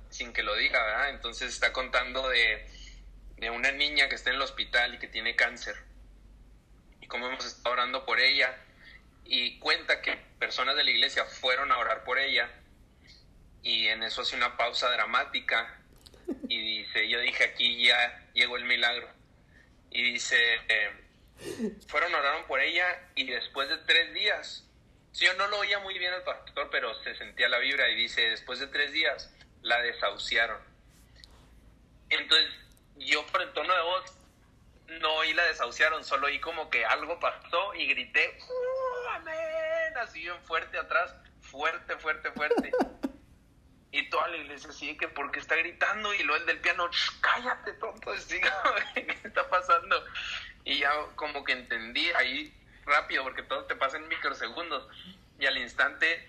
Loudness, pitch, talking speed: -28 LUFS, 175 Hz, 165 wpm